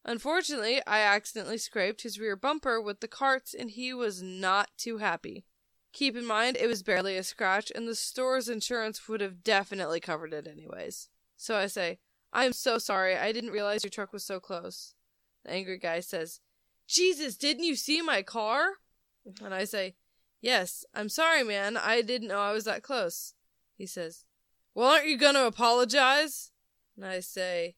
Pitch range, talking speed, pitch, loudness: 195-255 Hz, 180 wpm, 220 Hz, -29 LUFS